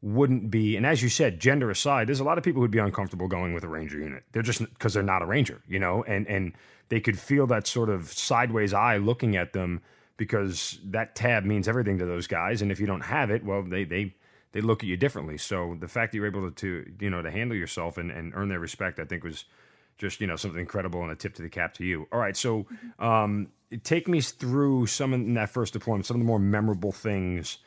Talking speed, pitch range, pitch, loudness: 255 wpm, 95-115 Hz, 105 Hz, -28 LUFS